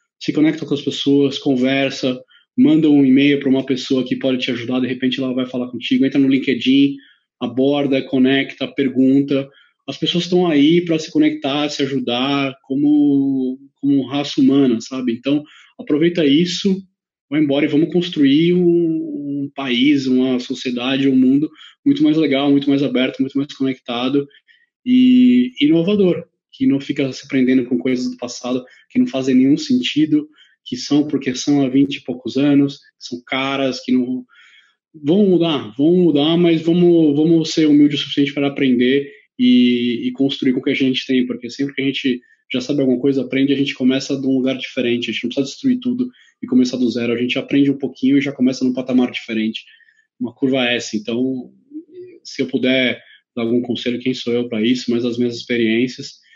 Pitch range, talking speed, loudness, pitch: 130-155 Hz, 185 wpm, -17 LUFS, 140 Hz